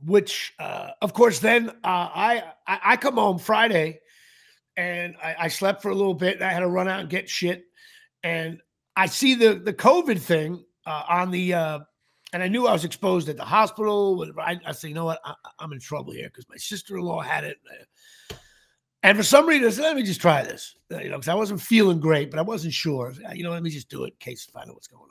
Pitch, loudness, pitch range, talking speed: 185 Hz, -23 LUFS, 165-215 Hz, 250 wpm